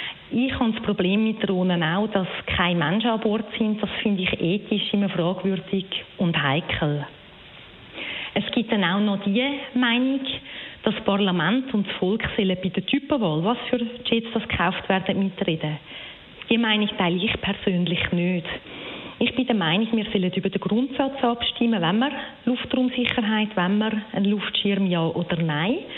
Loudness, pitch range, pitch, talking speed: -23 LUFS, 185-235 Hz, 205 Hz, 160 wpm